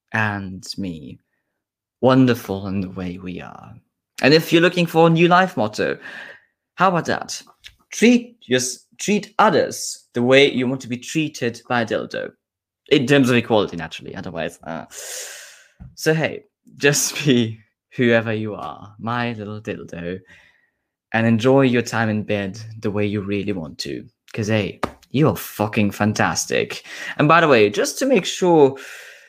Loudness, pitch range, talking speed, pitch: -19 LUFS, 105-135 Hz, 155 wpm, 115 Hz